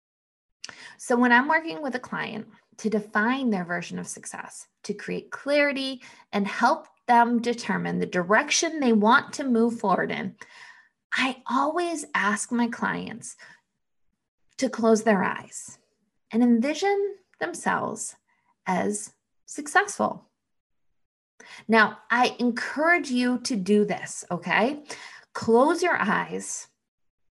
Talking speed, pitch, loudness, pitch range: 115 wpm, 240 Hz, -24 LUFS, 215-290 Hz